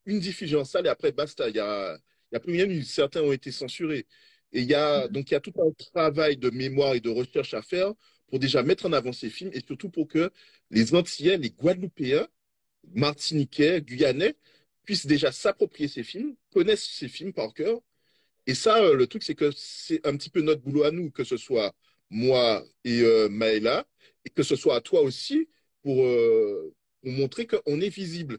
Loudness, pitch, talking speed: -26 LUFS, 165 Hz, 205 wpm